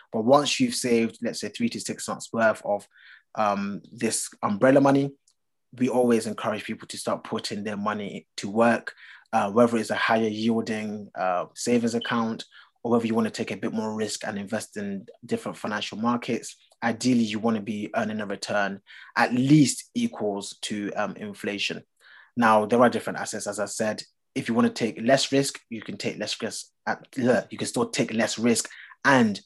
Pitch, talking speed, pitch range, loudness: 115 Hz, 195 wpm, 105-120 Hz, -25 LUFS